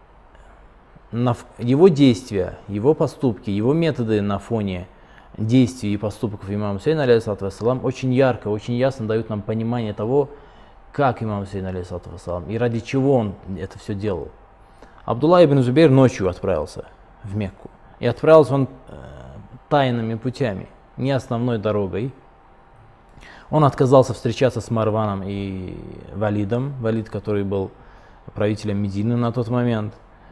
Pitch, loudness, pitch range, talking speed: 115 Hz, -20 LUFS, 100-130 Hz, 125 wpm